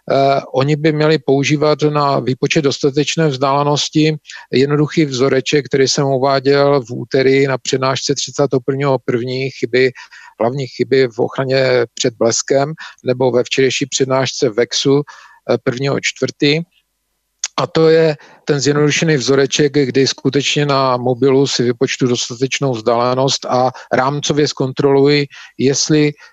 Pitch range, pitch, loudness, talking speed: 130-145 Hz, 135 Hz, -15 LUFS, 115 wpm